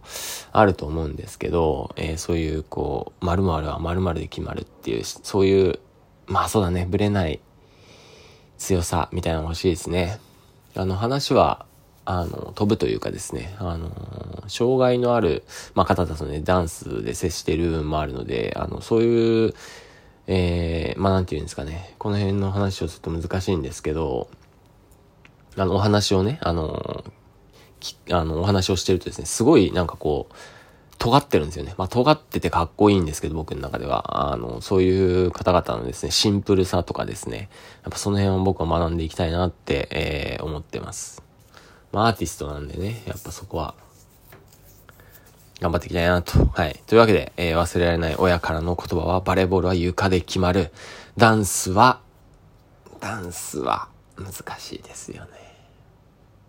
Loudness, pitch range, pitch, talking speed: -23 LUFS, 85-100 Hz, 90 Hz, 340 characters per minute